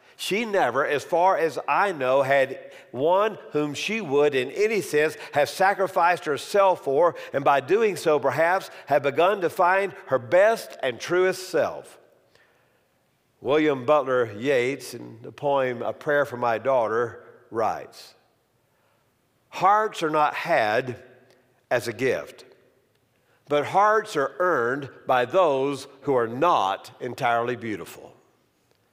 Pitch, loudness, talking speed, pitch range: 150 Hz, -23 LUFS, 130 wpm, 130-190 Hz